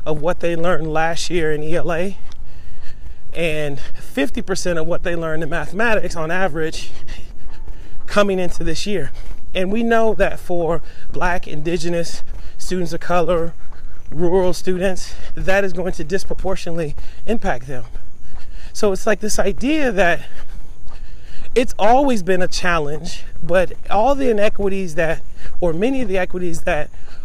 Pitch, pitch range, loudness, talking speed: 175 Hz, 160-190 Hz, -20 LUFS, 140 wpm